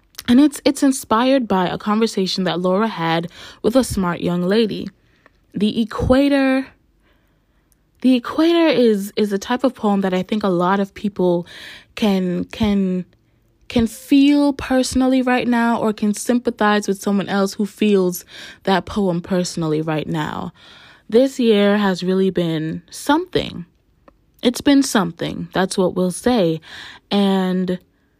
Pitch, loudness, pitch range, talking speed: 205 Hz, -18 LUFS, 185-245 Hz, 140 wpm